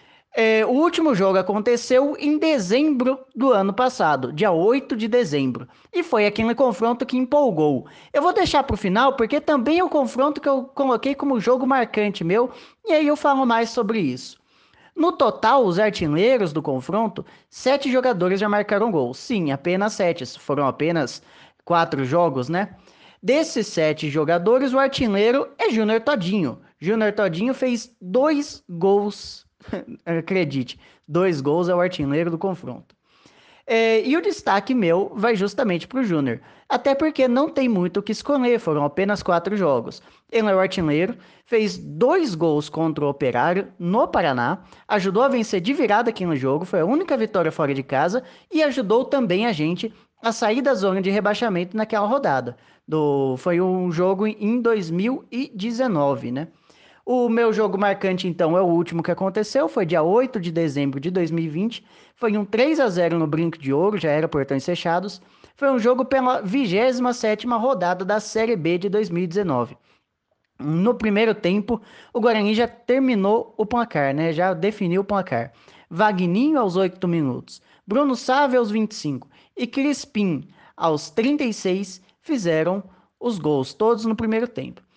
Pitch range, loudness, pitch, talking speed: 175-250 Hz, -21 LUFS, 210 Hz, 160 wpm